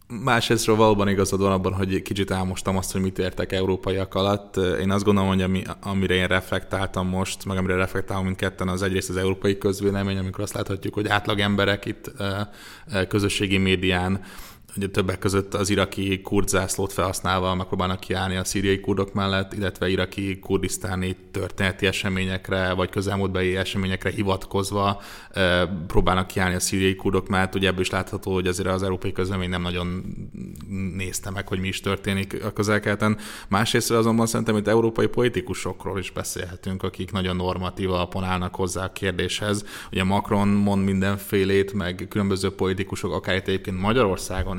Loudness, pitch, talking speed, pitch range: -24 LUFS, 95 Hz, 155 wpm, 95-100 Hz